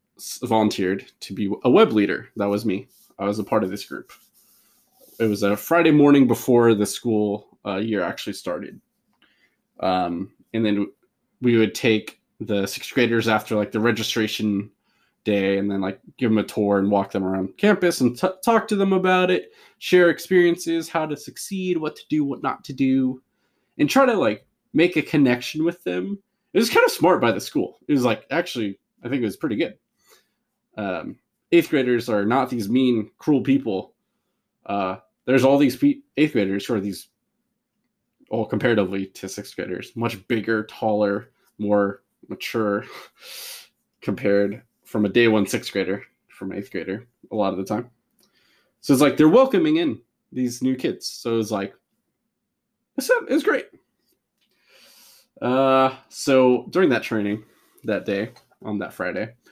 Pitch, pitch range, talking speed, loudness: 120 Hz, 105-150 Hz, 170 wpm, -22 LUFS